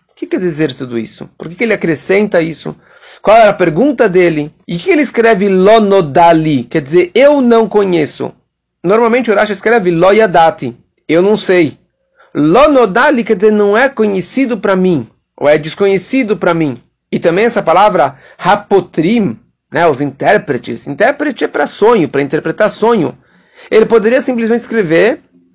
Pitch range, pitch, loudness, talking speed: 165-230 Hz, 195 Hz, -11 LUFS, 160 wpm